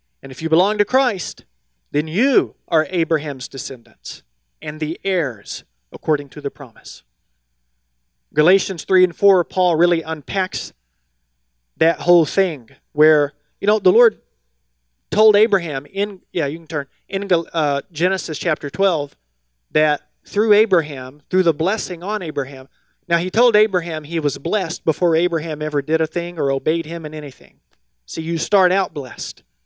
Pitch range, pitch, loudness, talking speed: 135-180 Hz, 160 Hz, -19 LUFS, 155 wpm